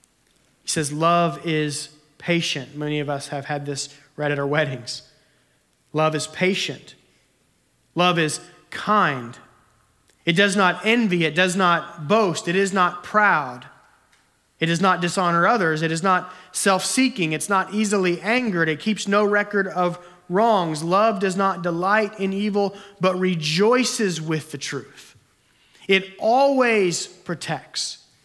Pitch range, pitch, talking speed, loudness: 155-195 Hz, 175 Hz, 145 wpm, -21 LUFS